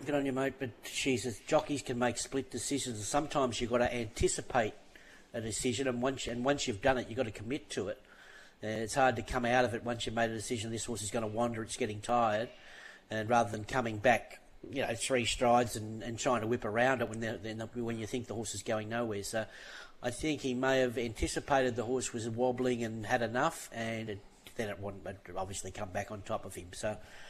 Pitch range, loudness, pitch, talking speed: 110-130 Hz, -34 LUFS, 120 Hz, 235 wpm